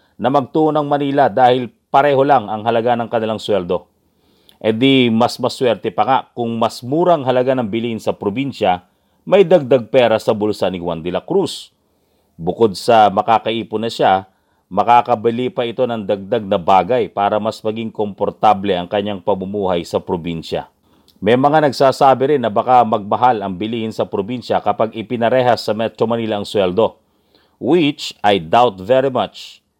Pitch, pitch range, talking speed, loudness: 115 Hz, 105-130 Hz, 160 wpm, -16 LUFS